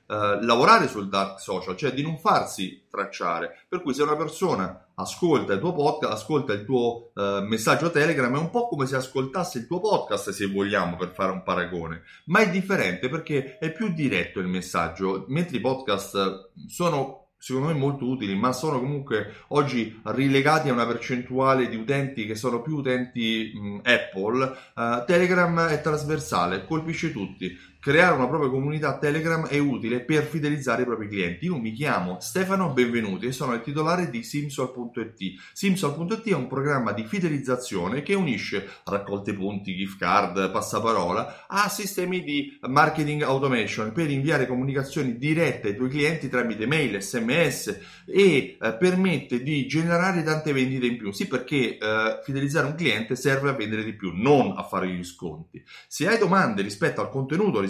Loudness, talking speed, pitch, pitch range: -25 LUFS, 165 wpm, 135 Hz, 110-155 Hz